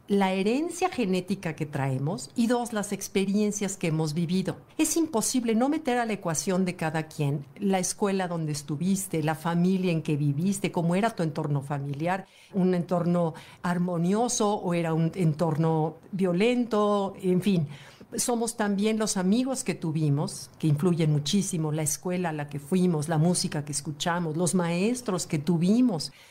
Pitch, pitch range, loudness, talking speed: 180 Hz, 160-200 Hz, -27 LUFS, 155 wpm